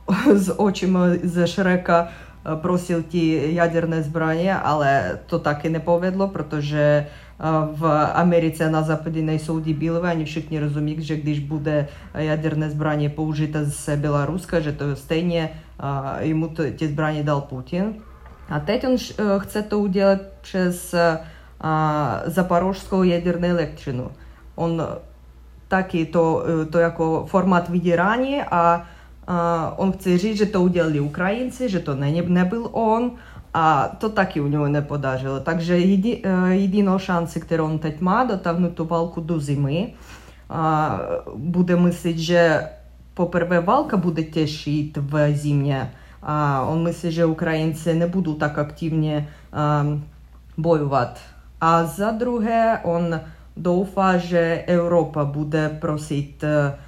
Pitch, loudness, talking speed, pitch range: 165 Hz, -21 LUFS, 120 wpm, 150-180 Hz